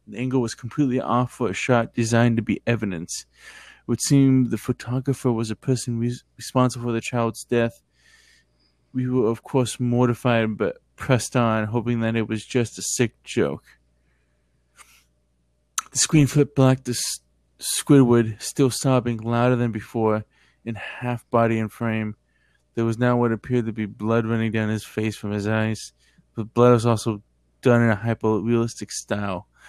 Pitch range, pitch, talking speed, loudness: 105-125 Hz, 115 Hz, 165 wpm, -22 LUFS